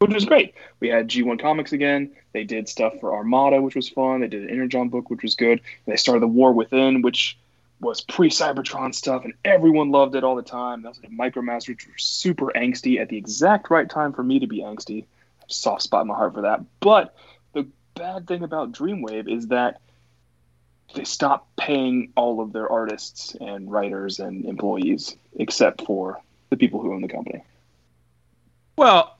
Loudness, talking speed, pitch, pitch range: -21 LUFS, 190 wpm, 125 Hz, 110-140 Hz